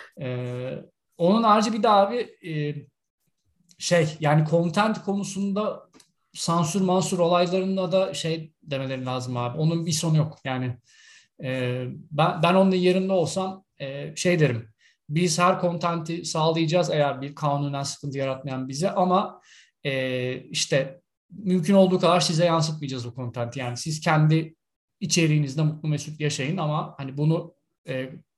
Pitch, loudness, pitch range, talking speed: 160 Hz, -24 LUFS, 140-180 Hz, 135 wpm